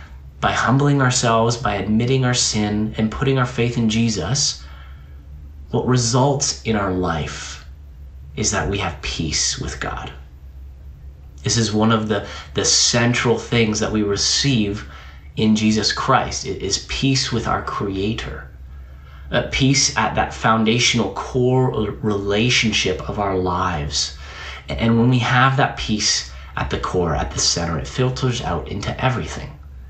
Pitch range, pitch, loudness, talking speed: 70-120 Hz, 105 Hz, -19 LUFS, 145 wpm